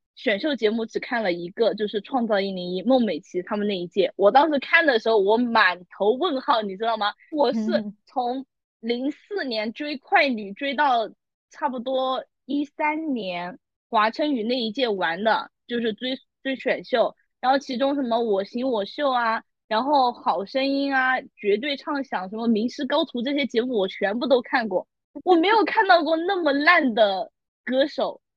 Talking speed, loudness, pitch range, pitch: 255 characters per minute, -23 LUFS, 215-285 Hz, 255 Hz